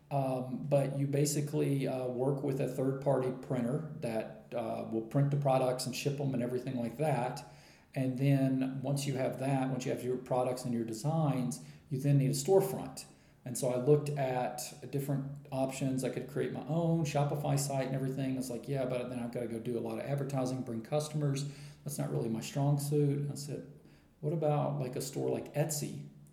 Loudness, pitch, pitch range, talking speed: -34 LUFS, 135 Hz, 125-145 Hz, 210 wpm